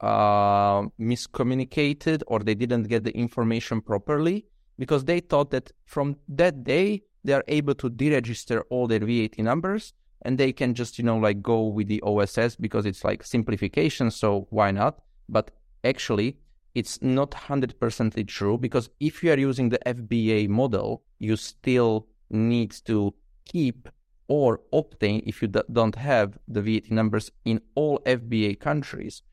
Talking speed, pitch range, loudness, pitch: 155 wpm, 110-135 Hz, -25 LUFS, 120 Hz